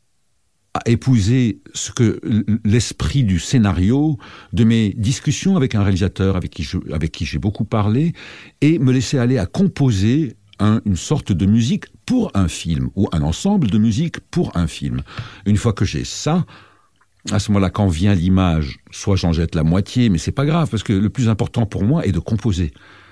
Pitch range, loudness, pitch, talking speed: 95-125 Hz, -18 LUFS, 105 Hz, 190 wpm